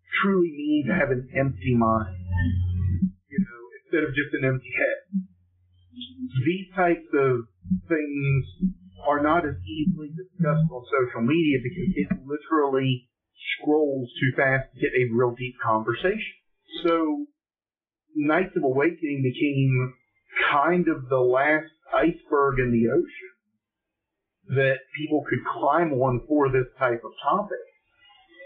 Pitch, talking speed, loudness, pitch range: 140 Hz, 130 wpm, -25 LUFS, 125-180 Hz